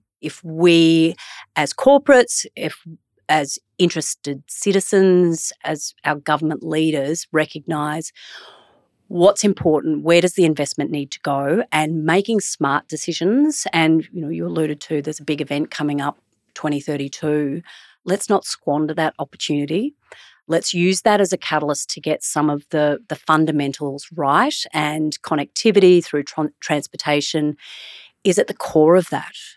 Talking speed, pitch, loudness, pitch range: 140 wpm, 155 Hz, -19 LUFS, 150-175 Hz